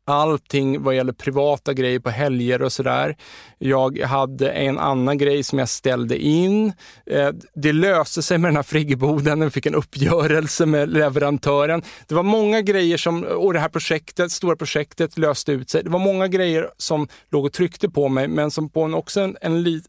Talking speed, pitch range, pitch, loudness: 190 wpm, 140-165 Hz, 150 Hz, -20 LUFS